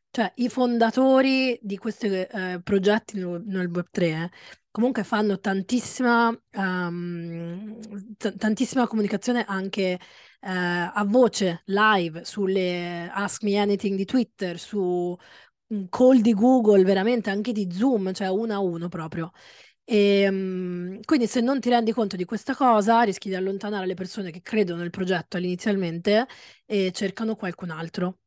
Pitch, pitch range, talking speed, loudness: 200 Hz, 185-225 Hz, 140 wpm, -24 LUFS